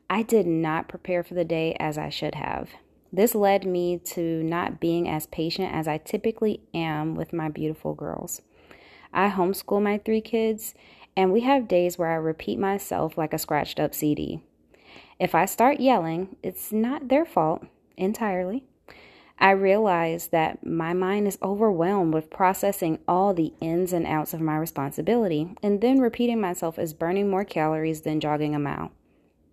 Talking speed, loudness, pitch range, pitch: 170 wpm, -25 LUFS, 160-205 Hz, 175 Hz